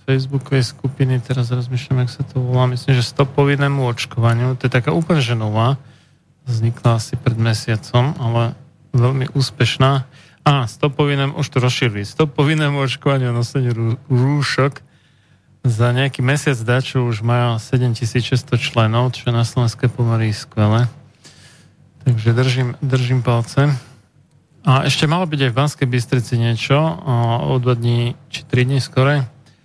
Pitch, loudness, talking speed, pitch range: 130 Hz, -18 LUFS, 140 wpm, 120-140 Hz